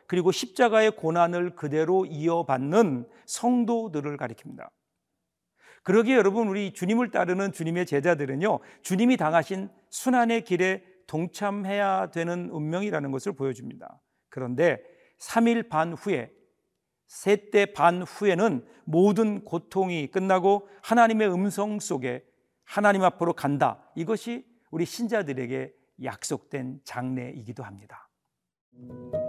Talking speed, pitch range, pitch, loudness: 275 characters per minute, 155-210 Hz, 185 Hz, -26 LUFS